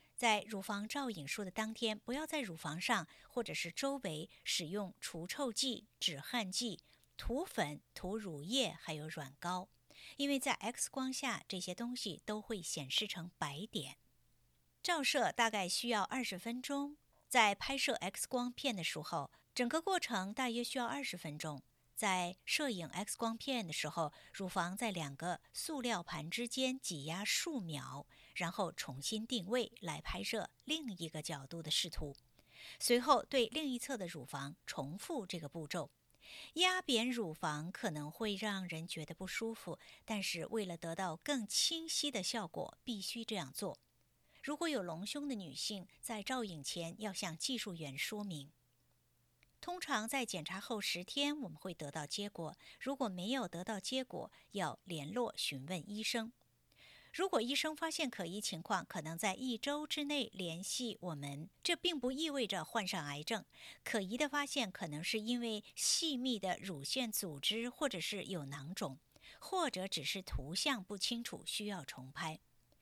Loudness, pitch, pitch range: -39 LUFS, 205 Hz, 170-250 Hz